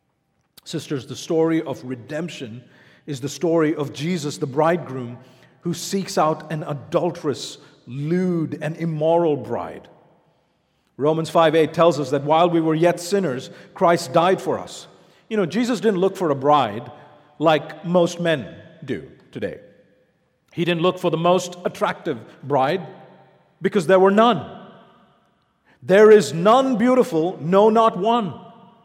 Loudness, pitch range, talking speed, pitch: -20 LUFS, 150-185 Hz, 140 wpm, 165 Hz